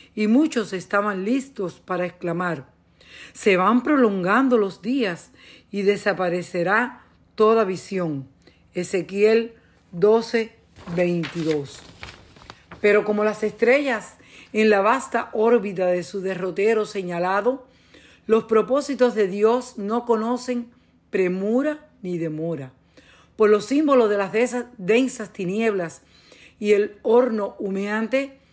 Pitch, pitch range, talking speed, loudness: 210 Hz, 185-235 Hz, 105 wpm, -22 LUFS